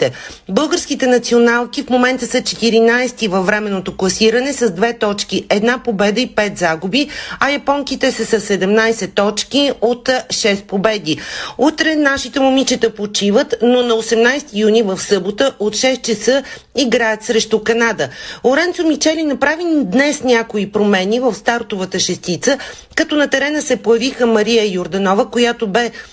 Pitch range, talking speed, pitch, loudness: 210-260 Hz, 140 wpm, 235 Hz, -15 LUFS